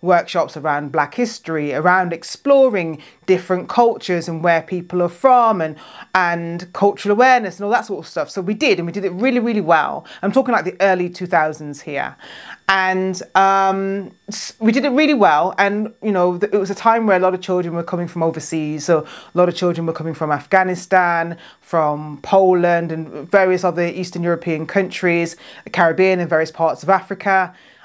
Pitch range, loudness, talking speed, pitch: 165-200 Hz, -17 LUFS, 185 wpm, 180 Hz